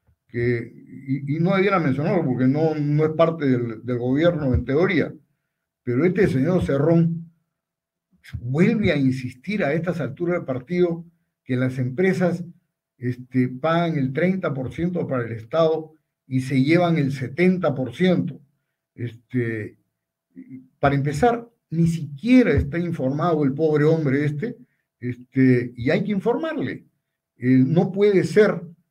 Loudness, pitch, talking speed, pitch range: -22 LUFS, 155 Hz, 130 wpm, 130-175 Hz